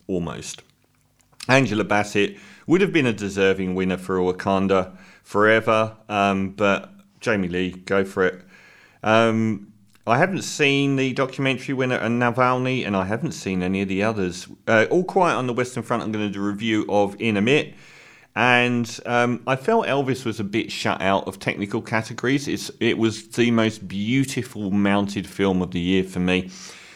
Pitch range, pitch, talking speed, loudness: 100-125 Hz, 110 Hz, 175 wpm, -22 LUFS